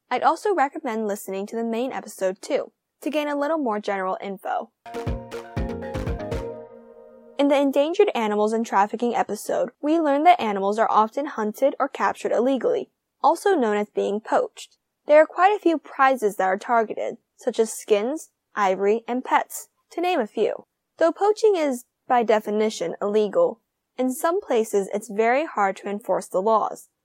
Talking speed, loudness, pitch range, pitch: 160 wpm, -23 LUFS, 210-295 Hz, 240 Hz